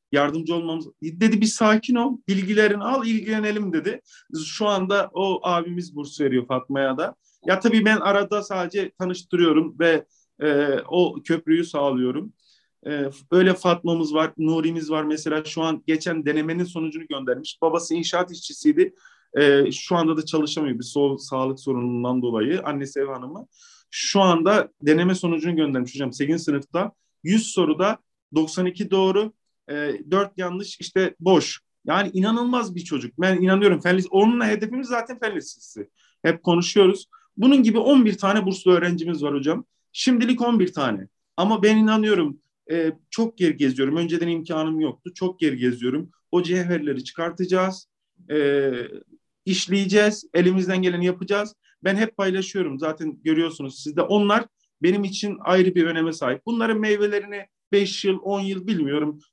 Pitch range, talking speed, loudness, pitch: 155-205 Hz, 145 wpm, -22 LUFS, 175 Hz